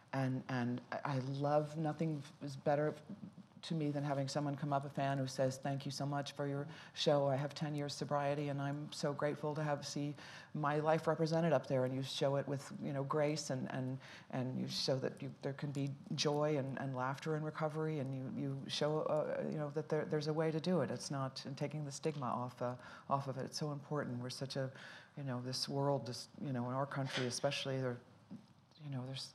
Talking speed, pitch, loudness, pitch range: 230 wpm, 140 Hz, -39 LUFS, 135-150 Hz